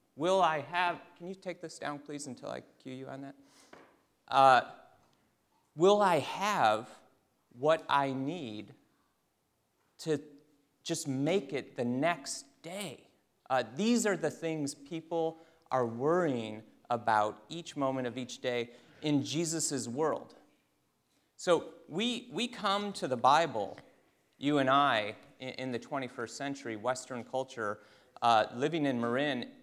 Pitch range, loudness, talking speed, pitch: 125-165 Hz, -32 LUFS, 135 wpm, 140 Hz